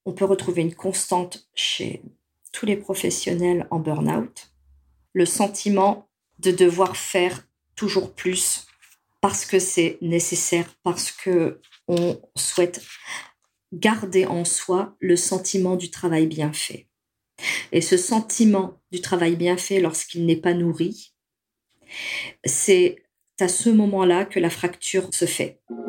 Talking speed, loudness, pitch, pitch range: 125 wpm, -22 LUFS, 180 Hz, 170-190 Hz